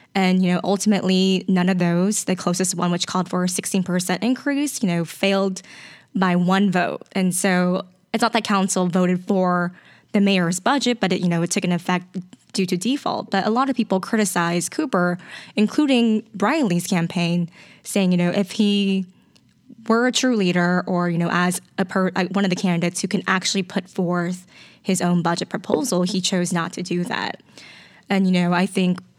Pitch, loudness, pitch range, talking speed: 185 Hz, -21 LUFS, 180-200 Hz, 195 wpm